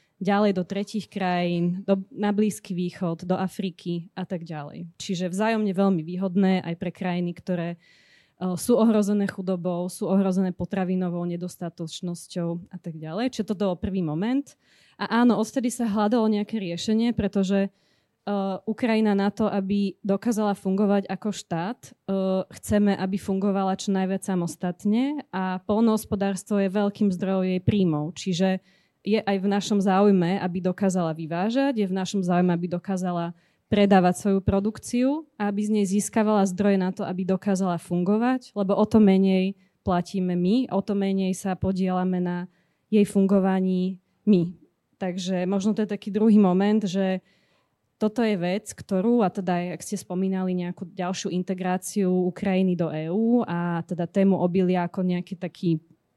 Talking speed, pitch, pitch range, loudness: 155 wpm, 190 Hz, 180-205 Hz, -25 LUFS